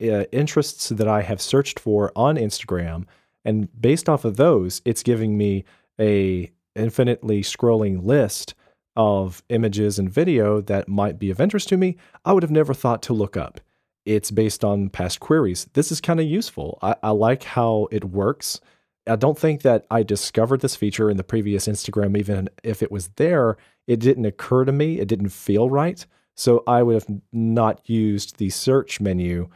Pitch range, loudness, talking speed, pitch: 100-130 Hz, -21 LUFS, 185 wpm, 110 Hz